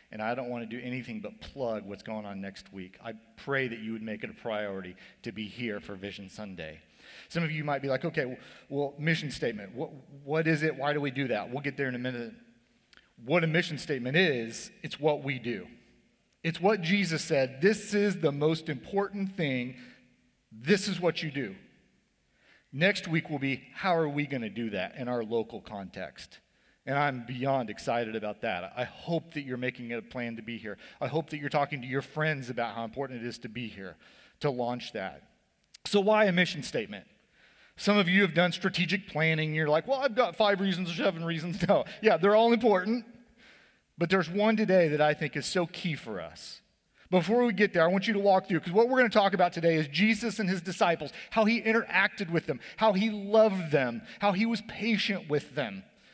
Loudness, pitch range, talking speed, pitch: -29 LUFS, 125-200 Hz, 220 wpm, 155 Hz